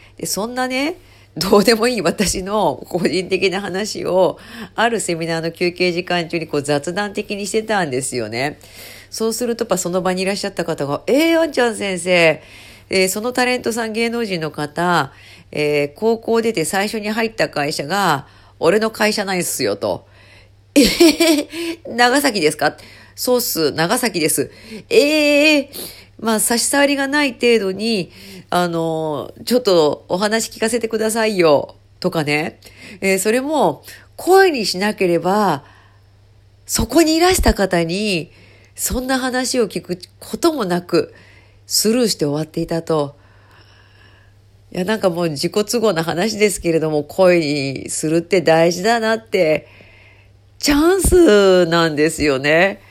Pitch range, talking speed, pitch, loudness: 150-225 Hz, 275 characters per minute, 185 Hz, -17 LUFS